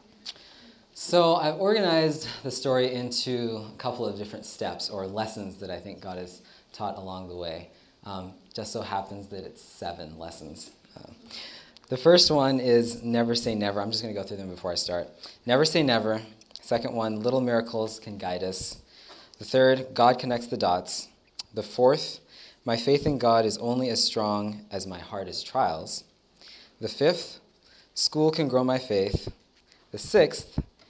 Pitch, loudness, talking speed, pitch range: 110 Hz, -26 LUFS, 170 wpm, 95-125 Hz